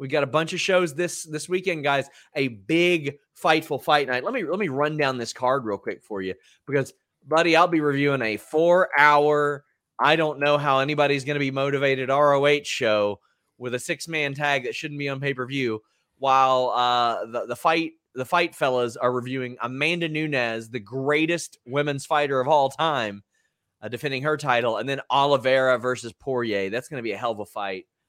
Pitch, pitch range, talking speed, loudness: 140 Hz, 125-155 Hz, 205 wpm, -23 LUFS